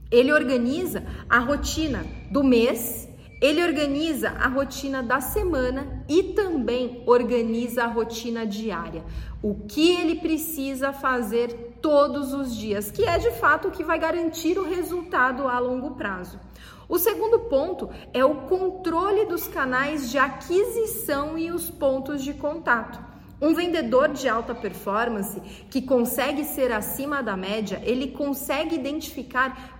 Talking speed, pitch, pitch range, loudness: 135 wpm, 275 Hz, 245-320 Hz, -24 LUFS